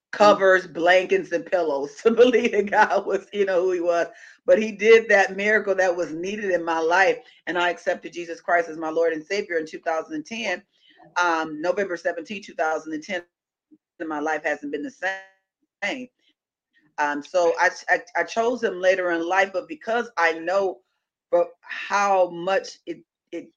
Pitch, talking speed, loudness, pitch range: 185 Hz, 165 wpm, -22 LUFS, 170-210 Hz